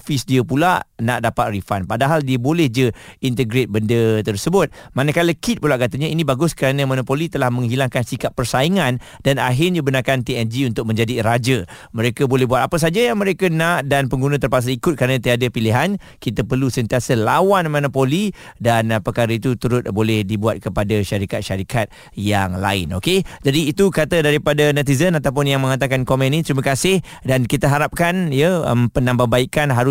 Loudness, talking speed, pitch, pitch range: -18 LUFS, 165 wpm, 130 Hz, 120-150 Hz